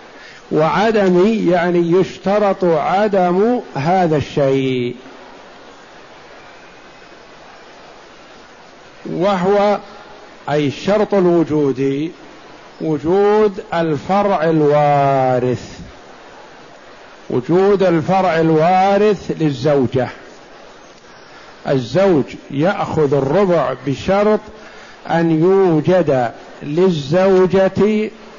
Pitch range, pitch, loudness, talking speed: 145-195 Hz, 175 Hz, -15 LUFS, 50 wpm